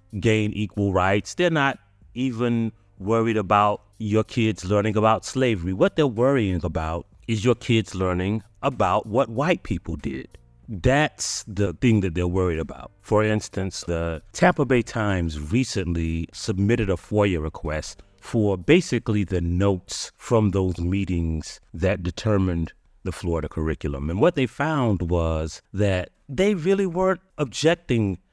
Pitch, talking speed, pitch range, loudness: 100 Hz, 140 wpm, 90-115 Hz, -23 LUFS